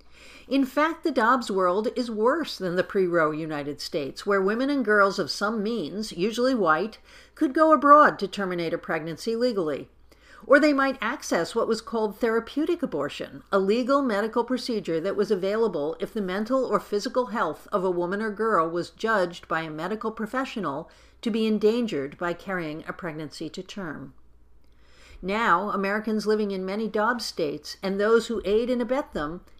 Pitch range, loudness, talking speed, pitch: 180-240 Hz, -25 LUFS, 170 wpm, 210 Hz